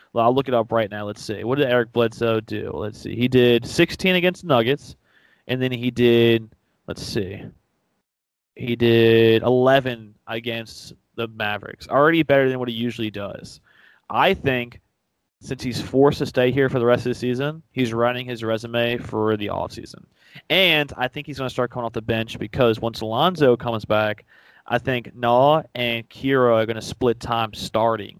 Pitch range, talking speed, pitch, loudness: 115-130 Hz, 190 wpm, 120 Hz, -21 LUFS